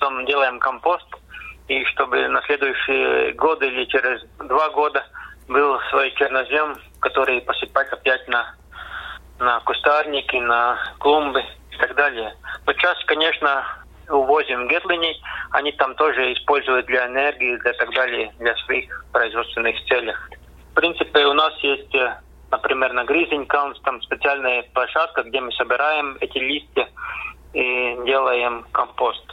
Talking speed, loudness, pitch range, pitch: 125 wpm, -20 LUFS, 125-145 Hz, 135 Hz